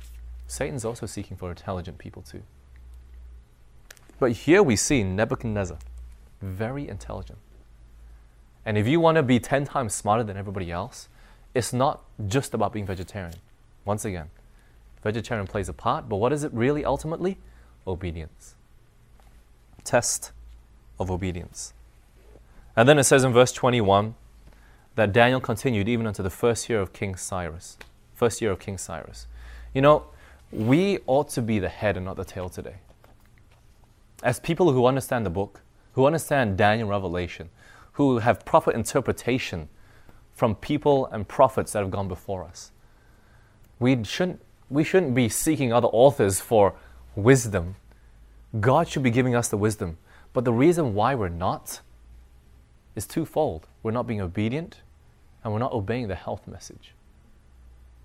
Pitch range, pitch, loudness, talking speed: 85-120 Hz, 105 Hz, -24 LUFS, 150 wpm